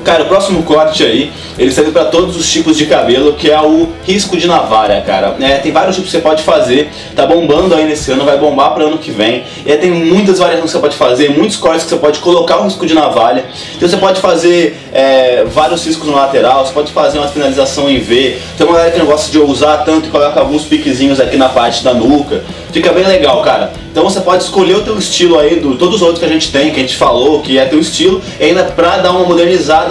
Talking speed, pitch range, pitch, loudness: 255 wpm, 145-175 Hz, 160 Hz, -9 LUFS